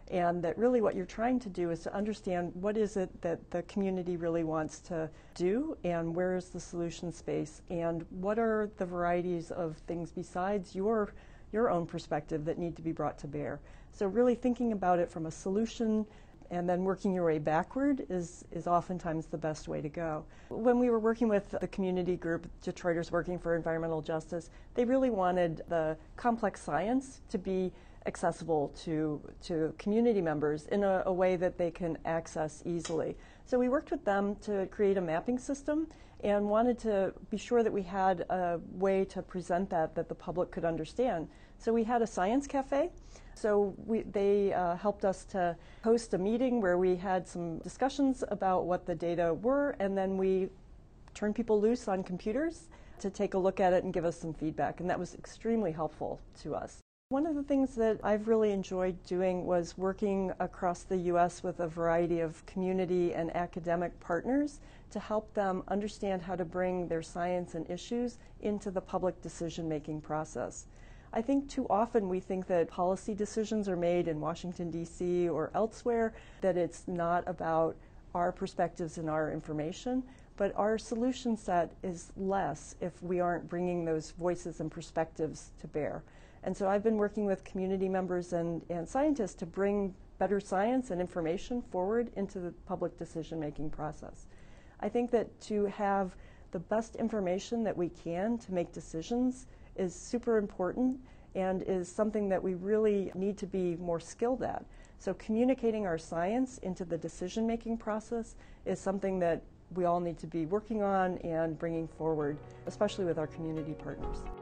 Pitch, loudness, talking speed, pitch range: 185 Hz, -34 LUFS, 180 wpm, 170-210 Hz